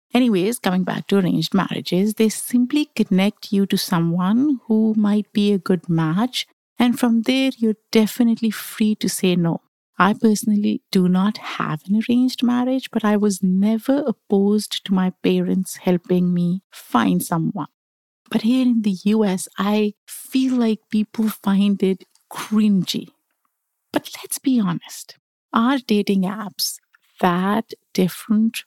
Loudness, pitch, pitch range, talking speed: -20 LUFS, 210 Hz, 190-230 Hz, 140 wpm